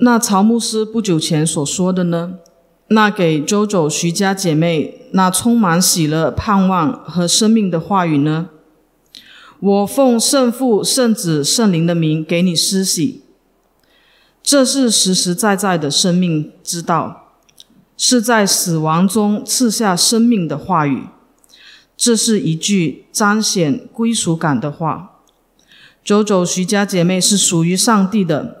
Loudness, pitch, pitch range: -14 LUFS, 190 Hz, 170-225 Hz